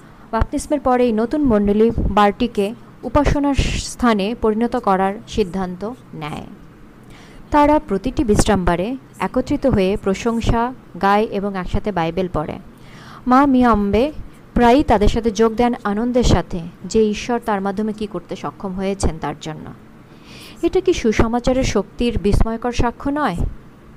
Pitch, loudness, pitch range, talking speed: 220 Hz, -18 LUFS, 195-250 Hz, 125 wpm